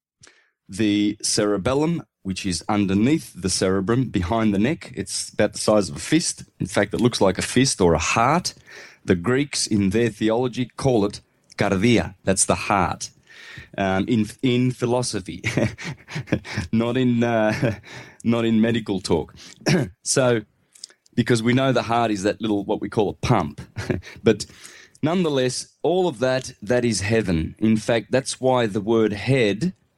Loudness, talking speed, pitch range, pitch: -22 LUFS, 155 wpm, 105-125 Hz, 115 Hz